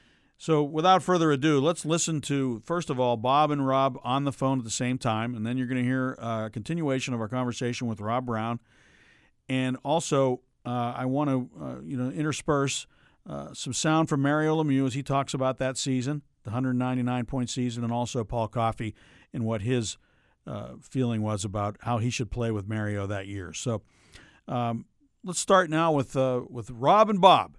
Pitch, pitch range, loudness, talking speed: 130 Hz, 115-140 Hz, -27 LUFS, 195 wpm